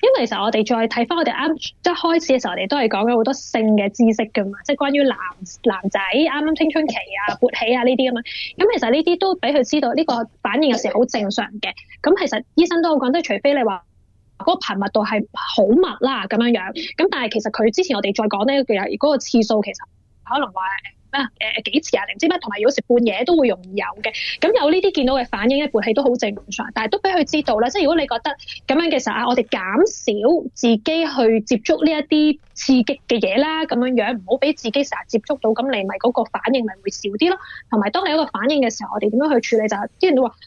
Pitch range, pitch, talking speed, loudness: 225-300 Hz, 250 Hz, 370 characters per minute, -19 LUFS